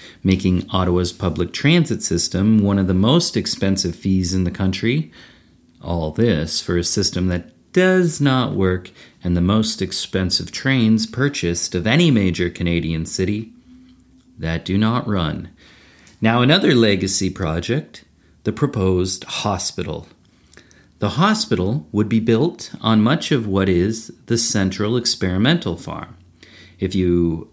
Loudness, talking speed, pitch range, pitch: -19 LUFS, 135 wpm, 90-115 Hz, 95 Hz